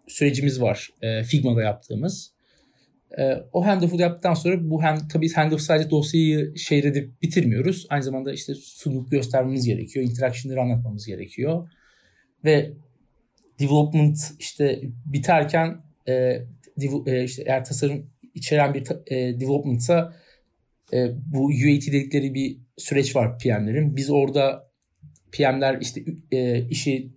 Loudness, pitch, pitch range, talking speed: -23 LUFS, 140 Hz, 130-155 Hz, 125 wpm